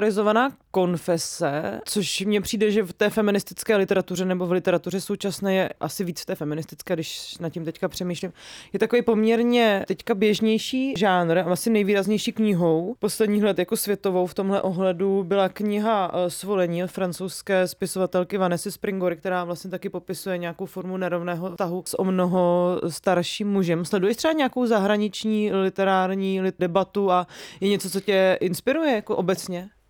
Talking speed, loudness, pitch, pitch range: 155 wpm, -24 LUFS, 190 Hz, 180-210 Hz